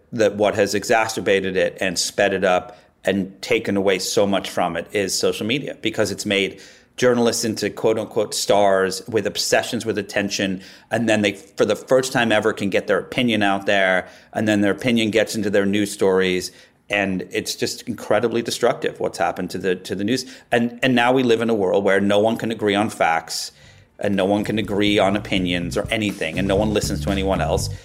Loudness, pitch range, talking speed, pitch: -20 LUFS, 95-110 Hz, 210 wpm, 105 Hz